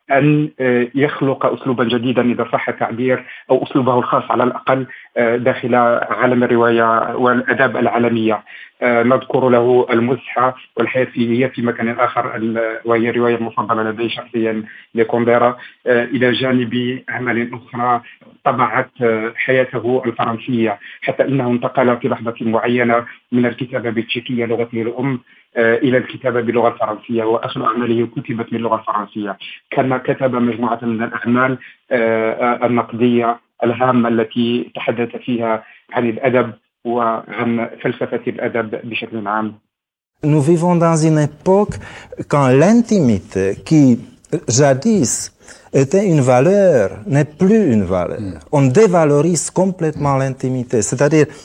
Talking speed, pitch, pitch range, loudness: 110 wpm, 120 Hz, 115-130 Hz, -16 LUFS